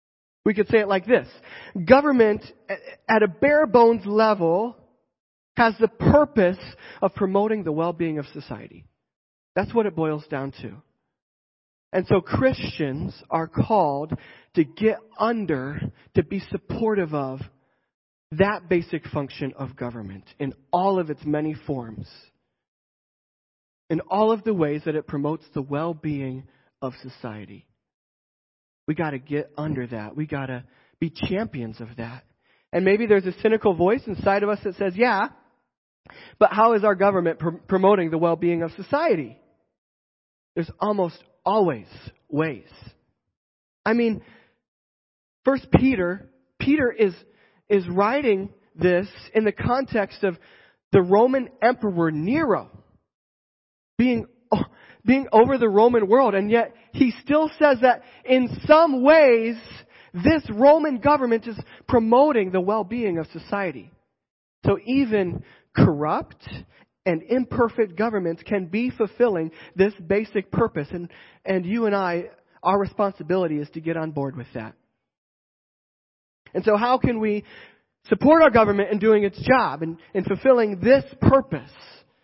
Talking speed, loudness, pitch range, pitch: 140 wpm, -22 LUFS, 150-220 Hz, 190 Hz